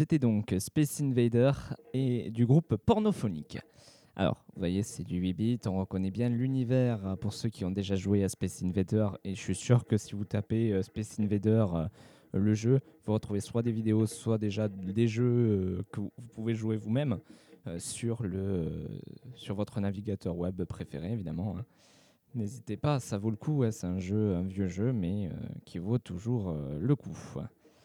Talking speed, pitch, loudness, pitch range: 170 wpm, 110 Hz, -32 LUFS, 95-120 Hz